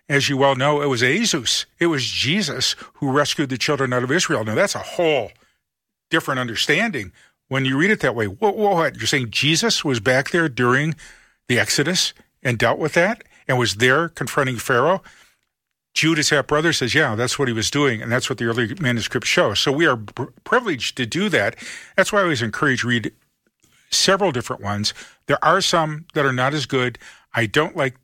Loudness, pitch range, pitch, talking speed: -19 LUFS, 125-160 Hz, 140 Hz, 205 wpm